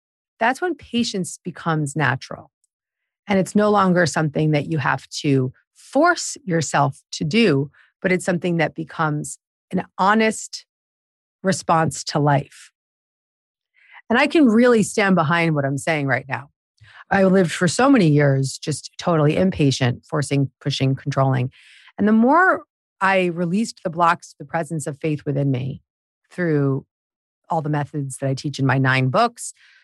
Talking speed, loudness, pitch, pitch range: 150 wpm, -20 LUFS, 160 Hz, 140-190 Hz